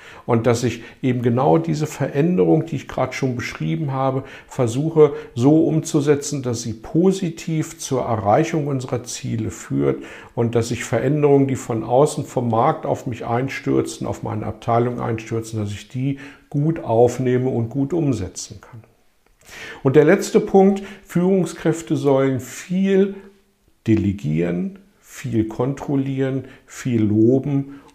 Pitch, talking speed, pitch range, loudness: 135 Hz, 130 wpm, 115-155 Hz, -20 LUFS